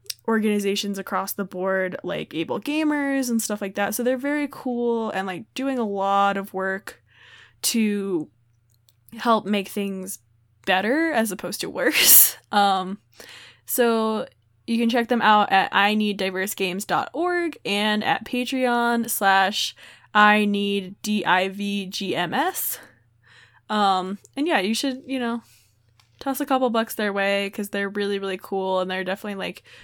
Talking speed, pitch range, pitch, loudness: 135 wpm, 190-235 Hz, 200 Hz, -22 LUFS